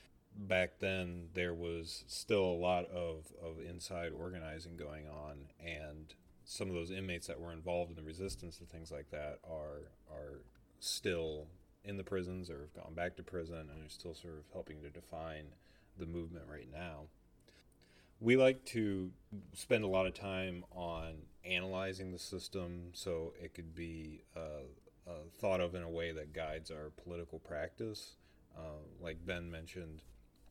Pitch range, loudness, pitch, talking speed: 80-90 Hz, -41 LUFS, 85 Hz, 165 wpm